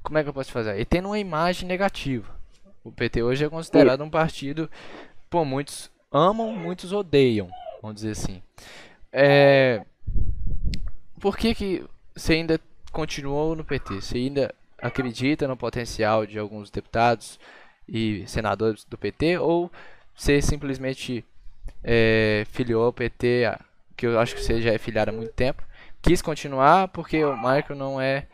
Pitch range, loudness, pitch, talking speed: 110-155 Hz, -24 LUFS, 130 Hz, 150 wpm